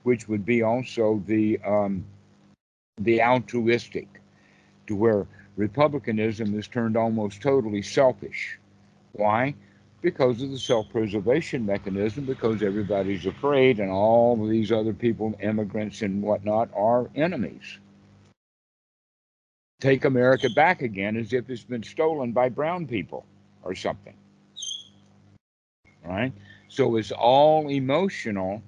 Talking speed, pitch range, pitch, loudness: 115 wpm, 100-125 Hz, 110 Hz, -24 LUFS